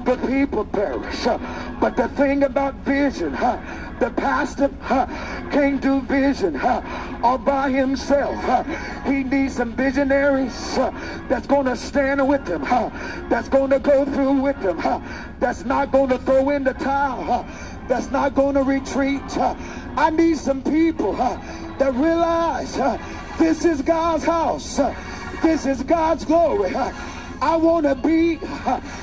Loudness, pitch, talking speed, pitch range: -21 LUFS, 275 Hz, 155 wpm, 270-315 Hz